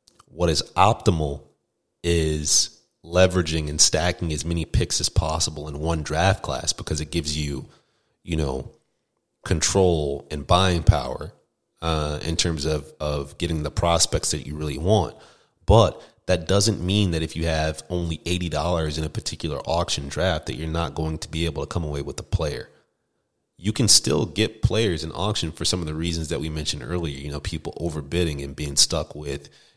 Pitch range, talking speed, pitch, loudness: 75-90 Hz, 185 wpm, 80 Hz, -23 LUFS